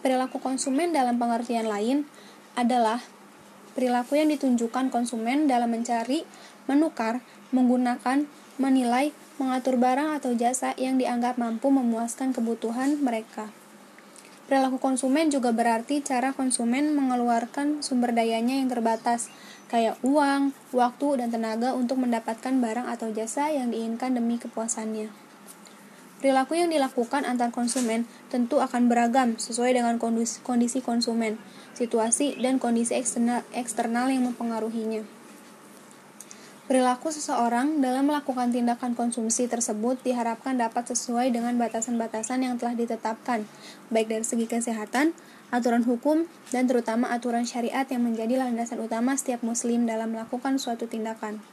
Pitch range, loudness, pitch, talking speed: 230-260 Hz, -26 LUFS, 245 Hz, 120 wpm